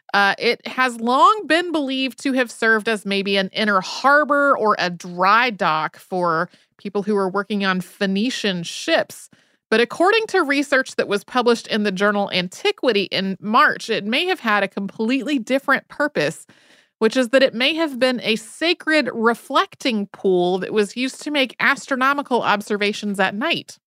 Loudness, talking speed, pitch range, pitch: -19 LUFS, 170 wpm, 200-275 Hz, 230 Hz